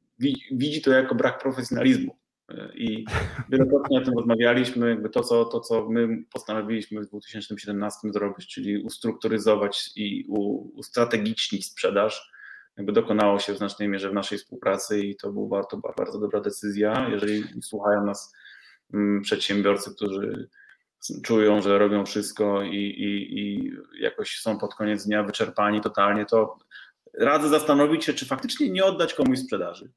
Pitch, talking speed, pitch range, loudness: 110 Hz, 140 wpm, 105-150 Hz, -25 LUFS